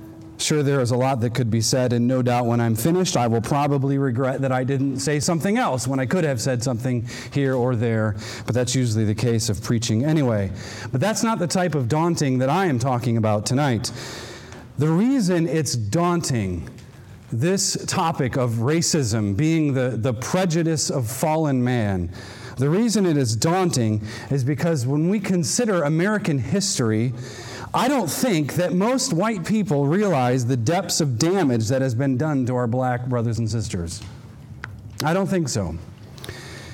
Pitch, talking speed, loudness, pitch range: 130 Hz, 175 wpm, -21 LUFS, 120-165 Hz